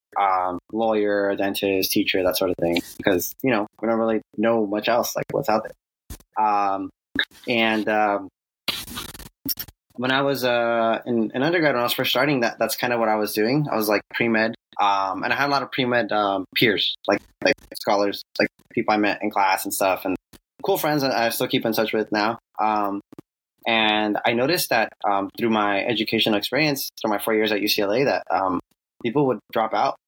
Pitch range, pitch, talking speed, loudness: 100-120 Hz, 110 Hz, 210 wpm, -22 LUFS